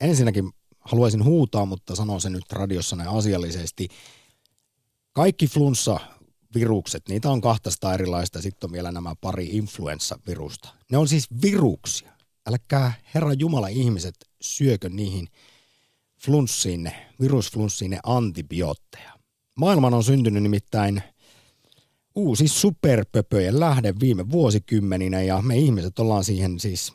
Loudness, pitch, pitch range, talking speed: -23 LUFS, 110 Hz, 95-130 Hz, 110 wpm